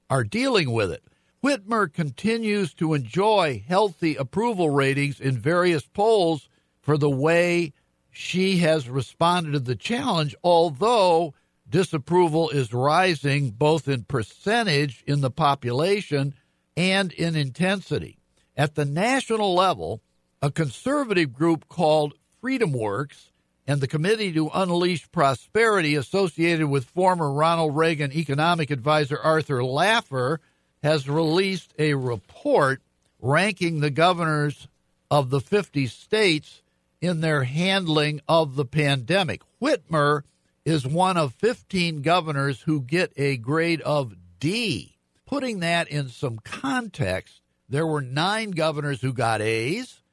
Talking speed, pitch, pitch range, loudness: 120 wpm, 155 Hz, 140-180 Hz, -23 LUFS